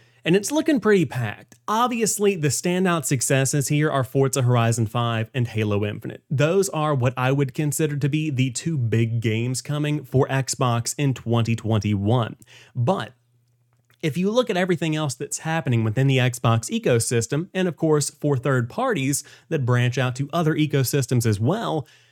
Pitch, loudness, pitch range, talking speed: 135 Hz, -22 LUFS, 120-155 Hz, 165 wpm